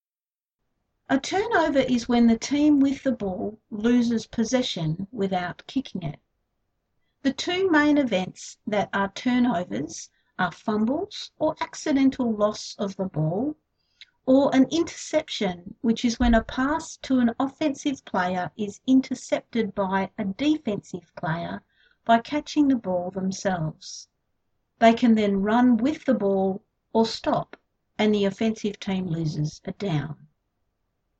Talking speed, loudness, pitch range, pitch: 130 wpm, -24 LUFS, 195-270 Hz, 230 Hz